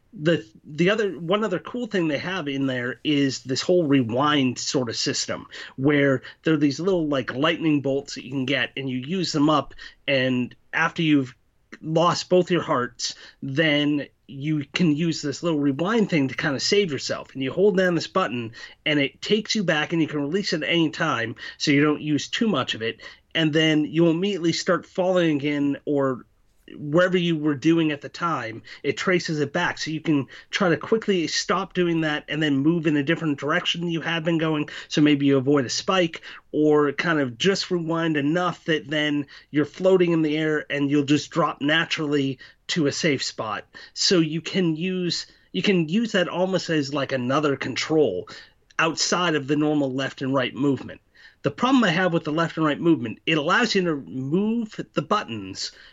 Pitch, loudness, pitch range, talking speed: 155 Hz, -23 LUFS, 140-175 Hz, 200 wpm